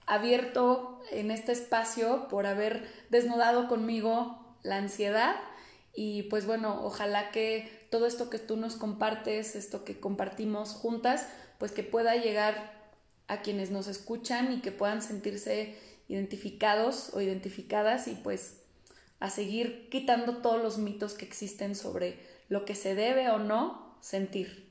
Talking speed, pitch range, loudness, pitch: 140 wpm, 205-235 Hz, -32 LUFS, 215 Hz